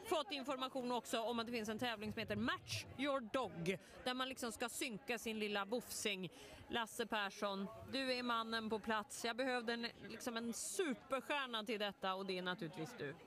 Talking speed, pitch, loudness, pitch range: 200 wpm, 230 Hz, -43 LUFS, 210-255 Hz